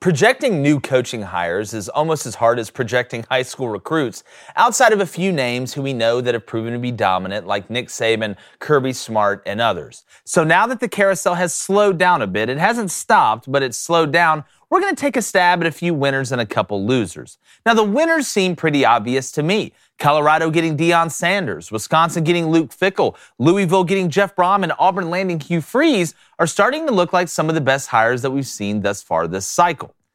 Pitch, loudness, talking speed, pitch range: 155 Hz, -18 LUFS, 215 wpm, 120-180 Hz